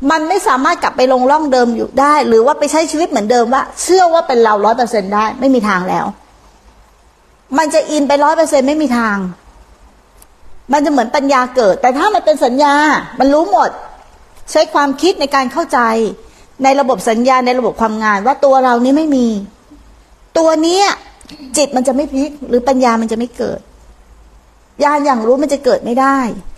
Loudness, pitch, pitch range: -12 LUFS, 270 Hz, 245-295 Hz